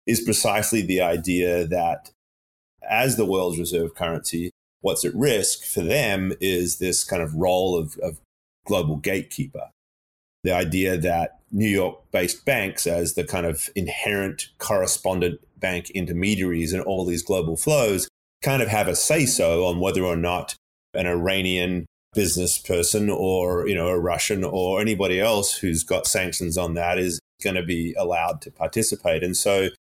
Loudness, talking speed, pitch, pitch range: -23 LUFS, 160 wpm, 90 Hz, 85-95 Hz